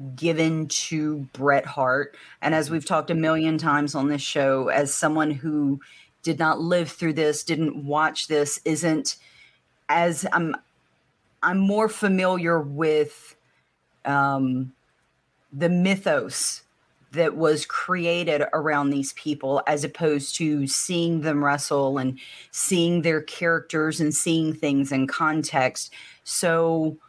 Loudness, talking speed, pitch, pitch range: -23 LUFS, 125 wpm, 155 Hz, 145-165 Hz